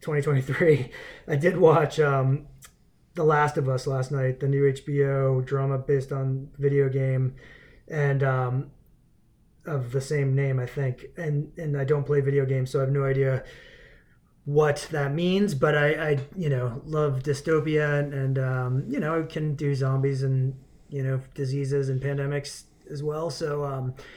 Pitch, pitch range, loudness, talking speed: 140 Hz, 135-150 Hz, -25 LUFS, 170 wpm